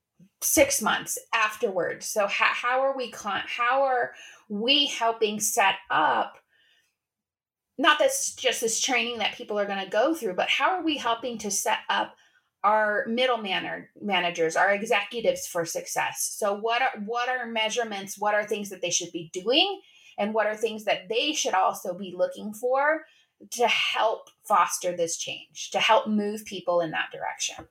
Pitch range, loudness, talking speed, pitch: 200-260 Hz, -25 LUFS, 170 wpm, 220 Hz